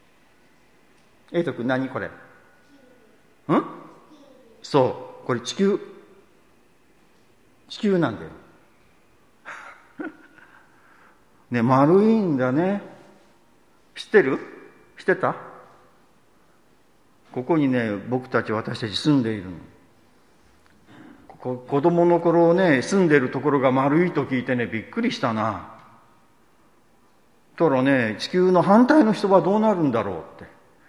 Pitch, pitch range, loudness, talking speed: 150 Hz, 125-195 Hz, -21 LUFS, 195 characters per minute